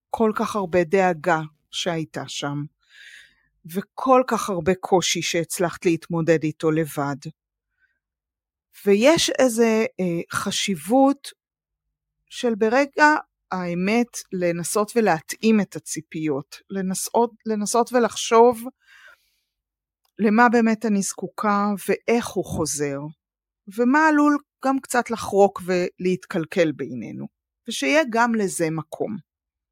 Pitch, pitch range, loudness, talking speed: 200 Hz, 170-235 Hz, -22 LUFS, 95 wpm